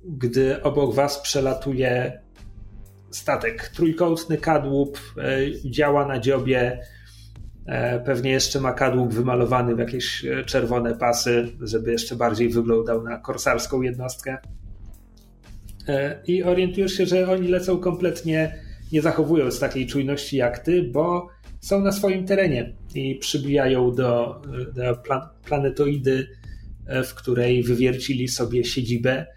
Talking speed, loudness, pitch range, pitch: 110 wpm, -23 LUFS, 120-145 Hz, 130 Hz